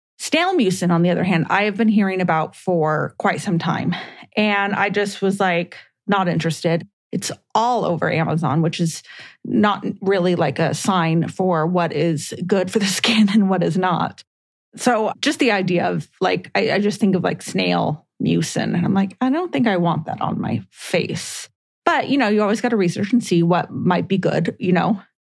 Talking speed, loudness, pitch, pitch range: 205 wpm, -19 LUFS, 190 Hz, 170-210 Hz